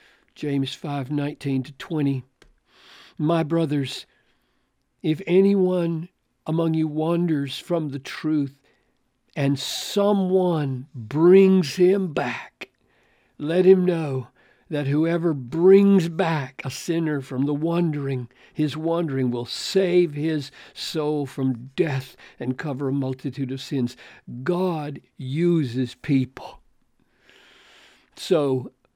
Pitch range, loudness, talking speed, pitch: 135-170 Hz, -23 LUFS, 105 wpm, 150 Hz